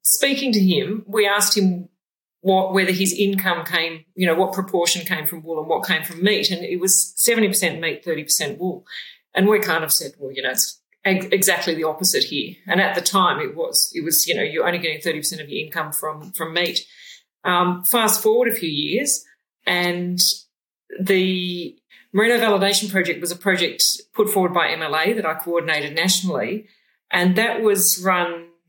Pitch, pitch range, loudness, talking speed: 185 Hz, 170-210 Hz, -19 LUFS, 190 wpm